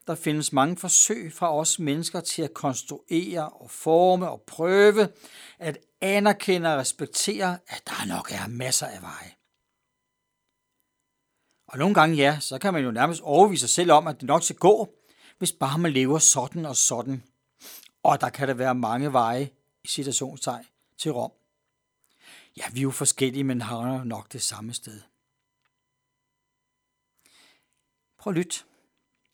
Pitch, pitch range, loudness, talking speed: 145 Hz, 130-170 Hz, -23 LUFS, 155 wpm